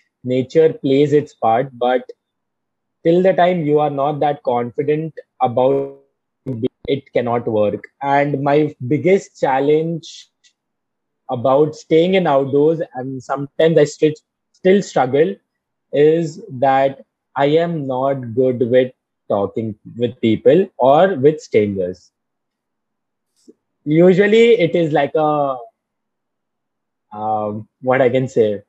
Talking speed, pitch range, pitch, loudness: 115 wpm, 130-160 Hz, 140 Hz, -16 LUFS